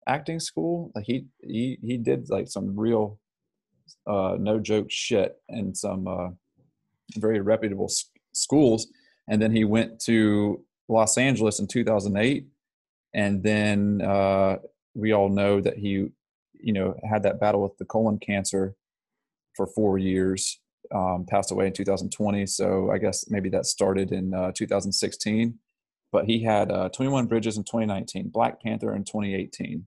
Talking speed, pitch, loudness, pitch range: 150 wpm, 105 Hz, -25 LUFS, 100-110 Hz